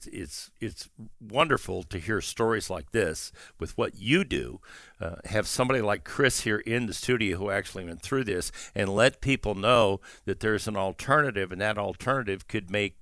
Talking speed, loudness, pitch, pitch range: 180 wpm, -28 LUFS, 105 Hz, 95-120 Hz